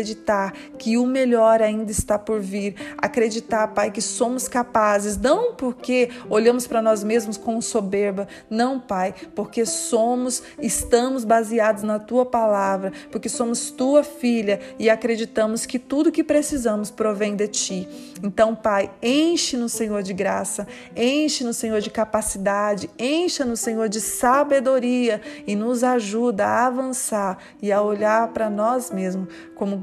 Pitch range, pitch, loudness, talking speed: 210-250 Hz, 225 Hz, -21 LUFS, 145 wpm